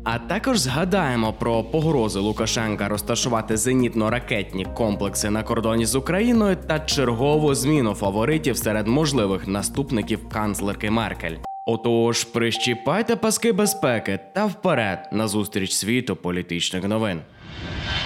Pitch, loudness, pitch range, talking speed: 115 Hz, -22 LUFS, 105-140 Hz, 110 wpm